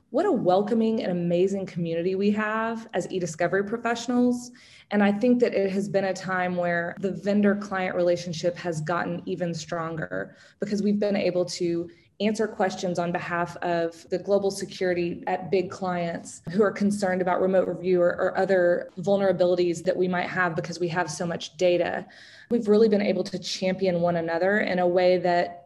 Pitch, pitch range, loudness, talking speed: 185 Hz, 175-200 Hz, -25 LUFS, 180 wpm